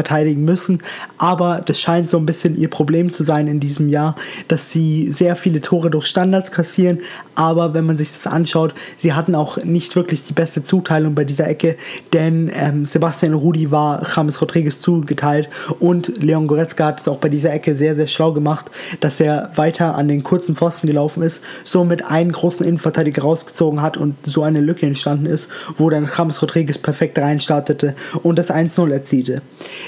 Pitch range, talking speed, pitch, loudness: 150-170 Hz, 185 wpm, 160 Hz, -17 LUFS